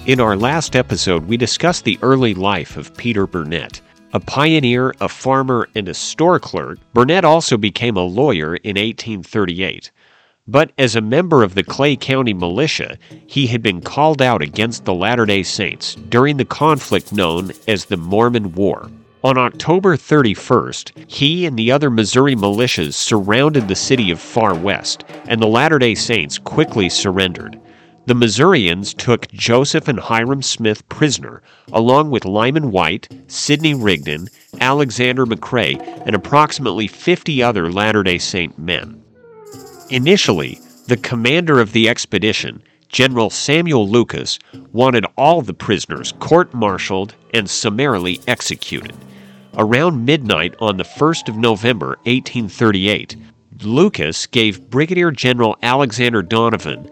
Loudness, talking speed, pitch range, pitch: -15 LUFS, 140 wpm, 105-135 Hz, 120 Hz